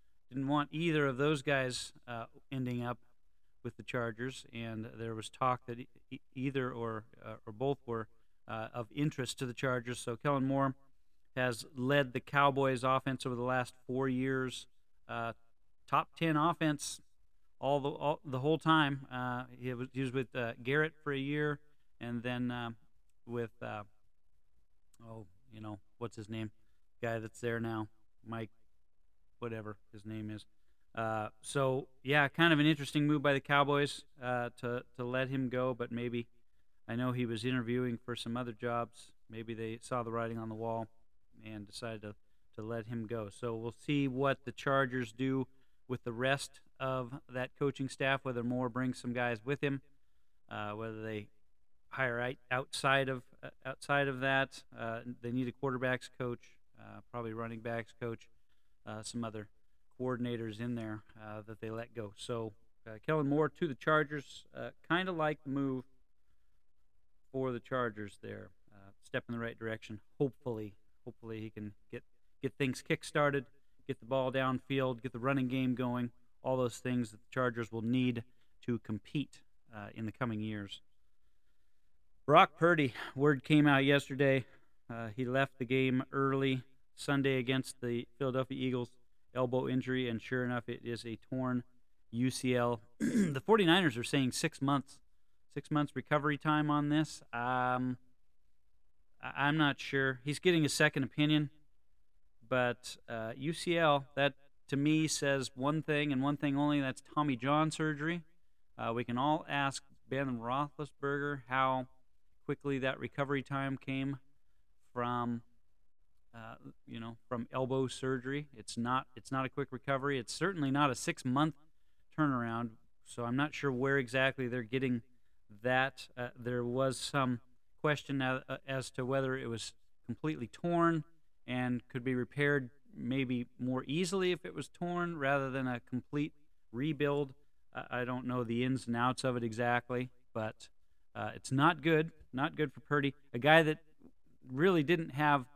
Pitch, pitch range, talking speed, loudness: 125 Hz, 115-140 Hz, 165 wpm, -35 LUFS